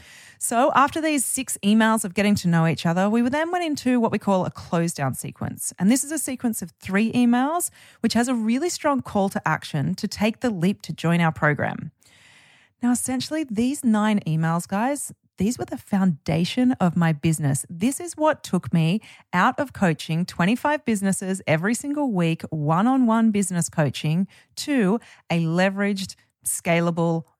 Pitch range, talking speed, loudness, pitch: 170-245 Hz, 175 wpm, -23 LUFS, 200 Hz